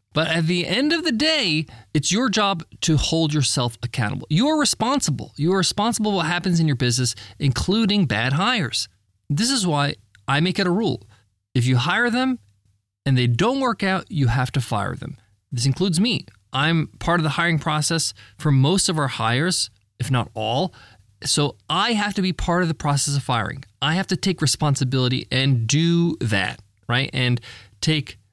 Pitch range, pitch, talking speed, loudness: 120-180 Hz, 145 Hz, 190 wpm, -21 LUFS